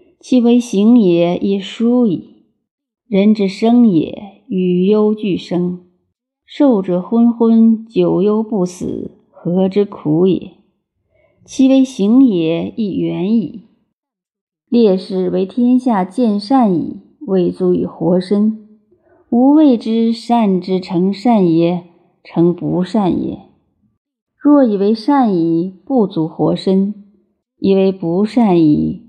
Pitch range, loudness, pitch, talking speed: 180-235 Hz, -14 LUFS, 200 Hz, 150 characters per minute